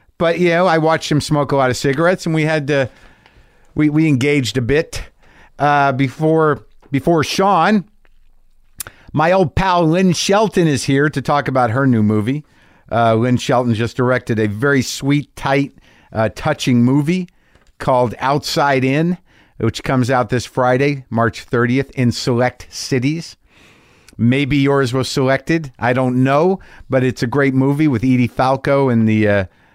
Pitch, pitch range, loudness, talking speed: 135 Hz, 125-150 Hz, -16 LUFS, 160 wpm